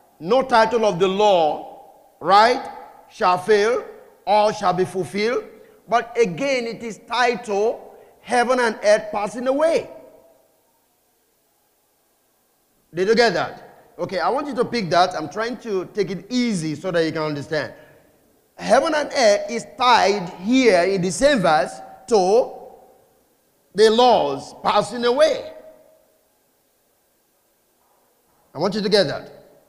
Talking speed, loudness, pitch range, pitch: 130 wpm, -19 LUFS, 195-280 Hz, 230 Hz